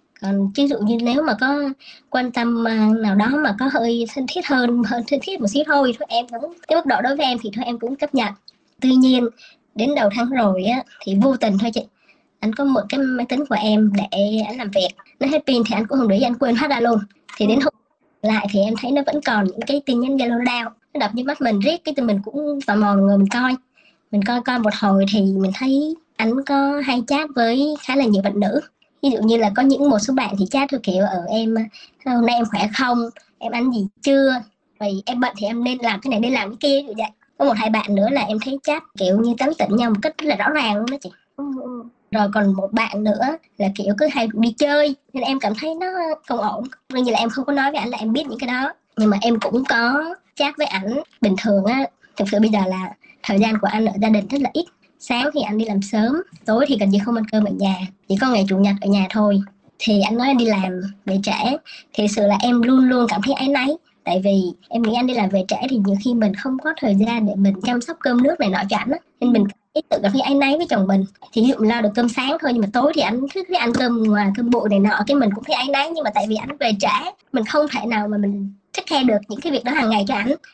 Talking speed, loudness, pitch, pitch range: 280 wpm, -19 LUFS, 235 Hz, 210-275 Hz